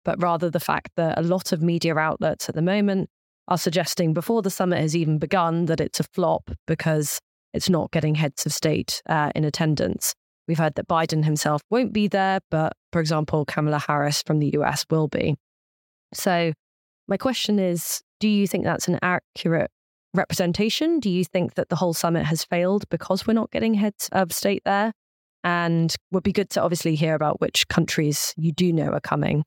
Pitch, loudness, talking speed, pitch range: 170 Hz, -23 LUFS, 195 wpm, 155-190 Hz